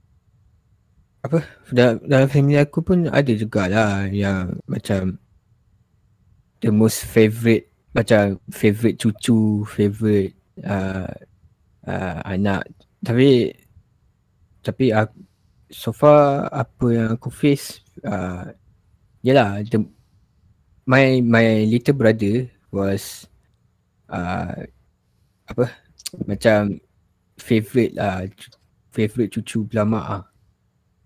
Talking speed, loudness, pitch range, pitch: 90 wpm, -19 LUFS, 100-120 Hz, 110 Hz